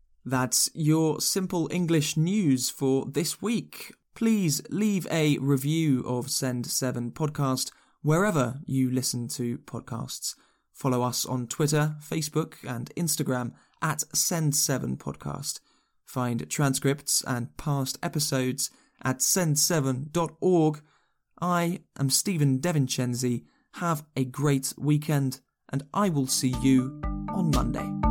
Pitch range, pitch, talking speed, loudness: 130-160 Hz, 140 Hz, 110 wpm, -27 LUFS